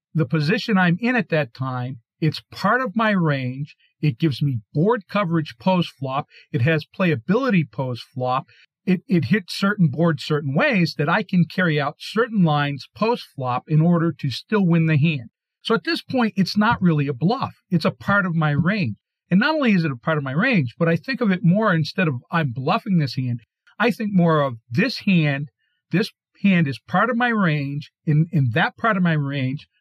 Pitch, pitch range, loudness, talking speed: 165 Hz, 145-200 Hz, -21 LUFS, 210 wpm